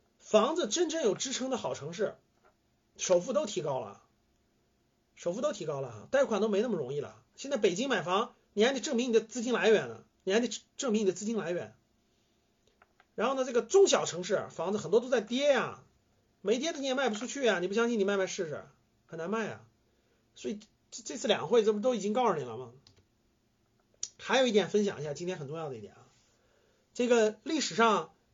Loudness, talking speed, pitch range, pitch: -31 LUFS, 295 characters per minute, 175-250 Hz, 220 Hz